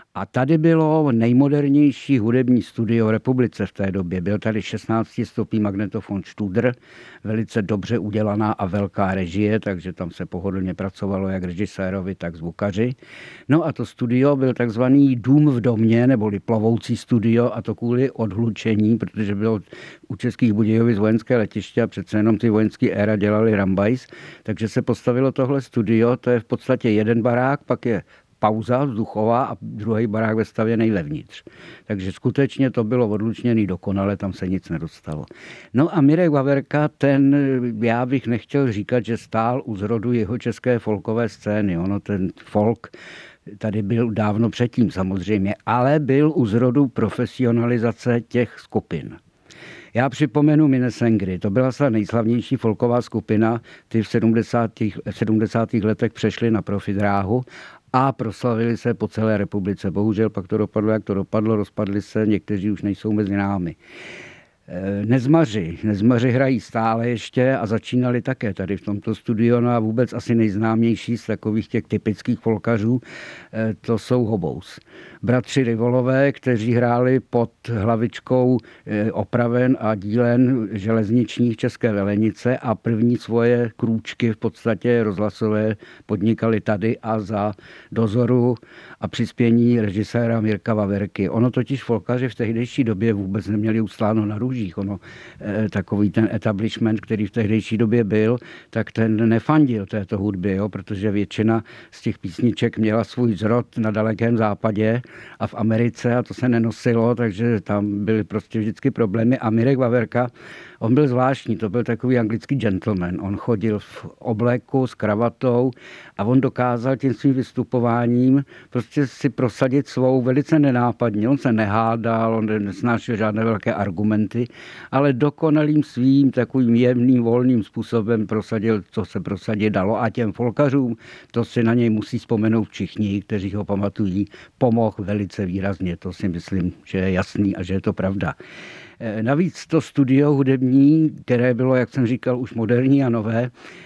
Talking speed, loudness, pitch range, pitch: 150 wpm, -20 LUFS, 105-125 Hz, 115 Hz